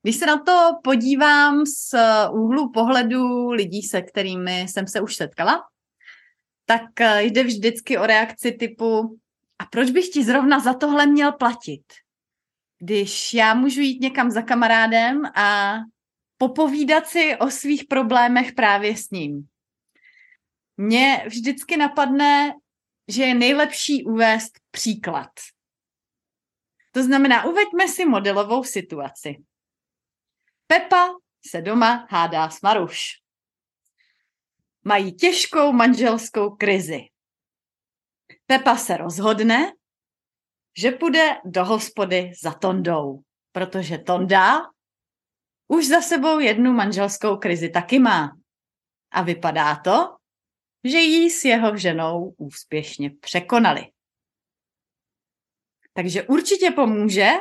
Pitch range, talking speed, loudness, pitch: 200-285 Hz, 105 wpm, -19 LUFS, 230 Hz